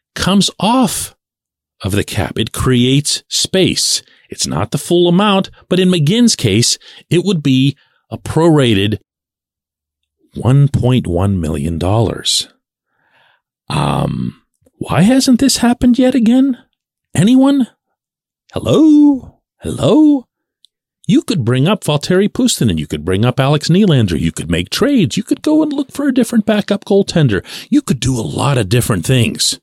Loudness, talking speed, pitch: -13 LUFS, 140 wpm, 155 Hz